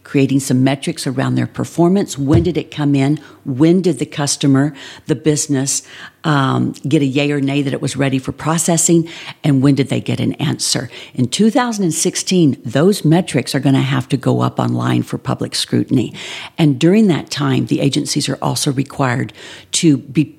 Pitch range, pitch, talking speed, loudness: 135-160 Hz, 145 Hz, 180 wpm, -16 LUFS